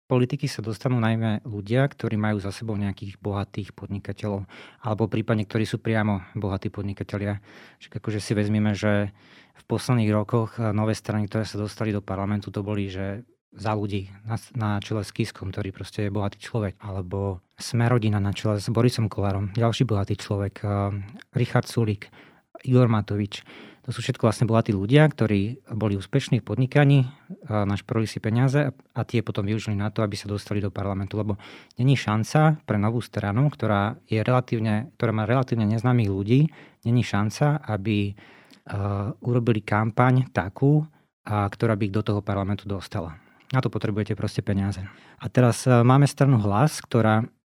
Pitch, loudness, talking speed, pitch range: 110 Hz, -25 LUFS, 160 wpm, 100-120 Hz